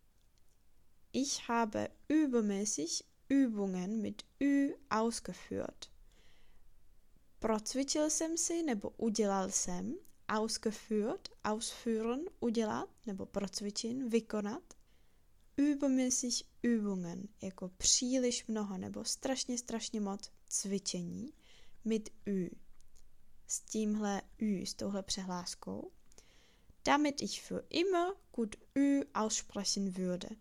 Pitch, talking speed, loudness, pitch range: 220 Hz, 90 wpm, -36 LUFS, 200-260 Hz